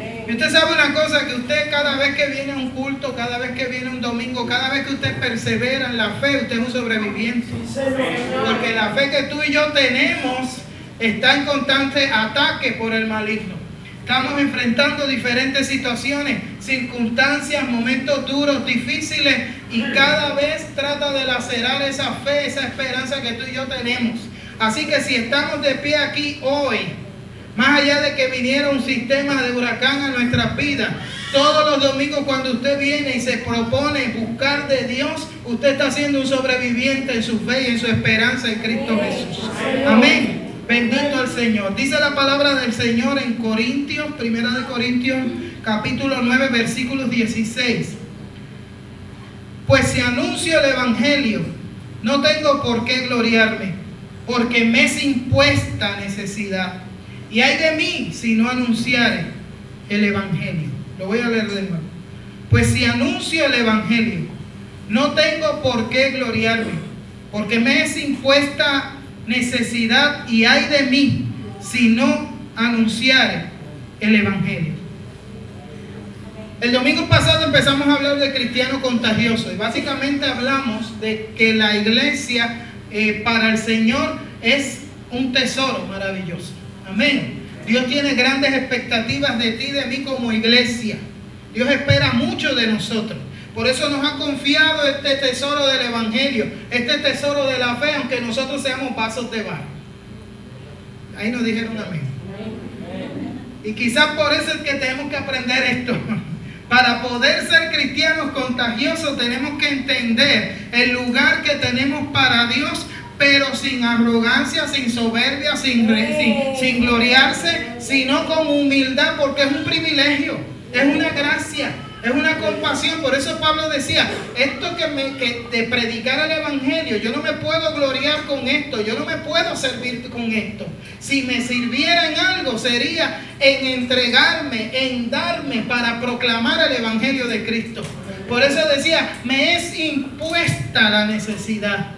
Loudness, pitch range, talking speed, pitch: -18 LUFS, 230-280 Hz, 145 wpm, 260 Hz